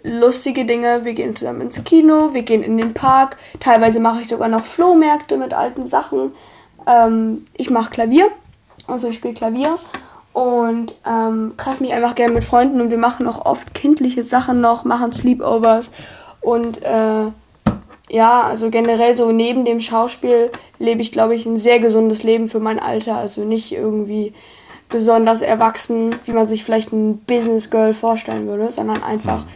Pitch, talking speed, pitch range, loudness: 230 Hz, 170 wpm, 225-245 Hz, -16 LUFS